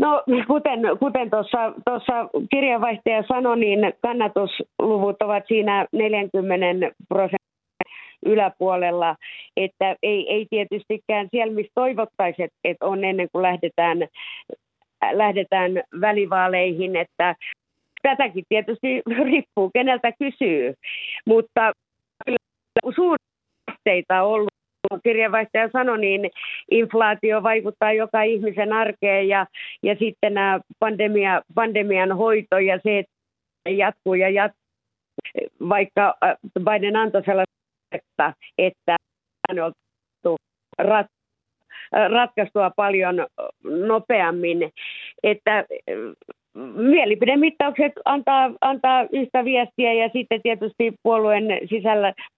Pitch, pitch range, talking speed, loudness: 215 Hz, 195-245 Hz, 90 wpm, -21 LUFS